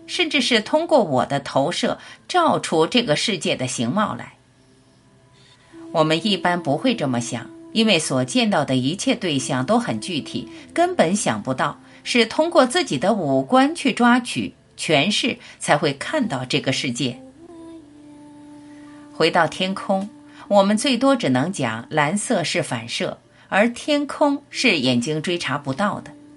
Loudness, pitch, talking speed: -20 LUFS, 215 Hz, 215 characters per minute